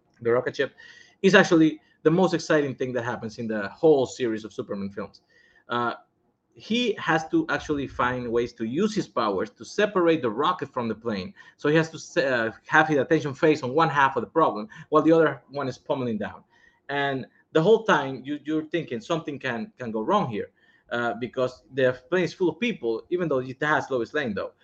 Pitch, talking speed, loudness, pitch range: 150 Hz, 210 wpm, -25 LUFS, 125-165 Hz